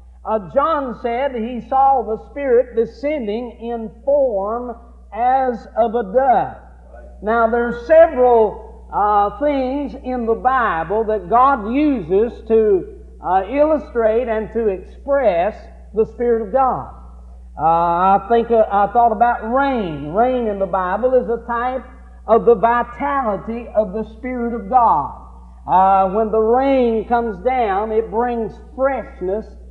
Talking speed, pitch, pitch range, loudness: 135 wpm, 235 Hz, 215-260 Hz, -17 LUFS